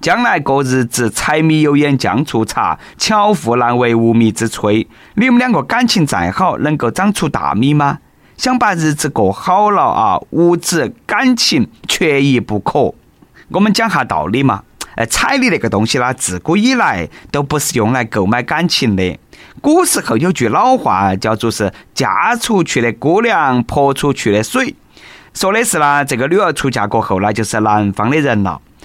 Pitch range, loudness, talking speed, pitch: 115-175 Hz, -13 LUFS, 250 characters per minute, 135 Hz